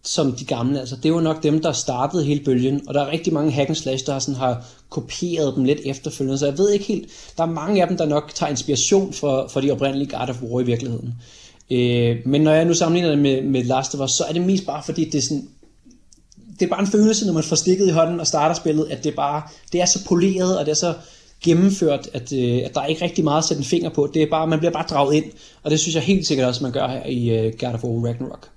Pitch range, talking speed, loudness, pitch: 135-165 Hz, 280 wpm, -20 LUFS, 150 Hz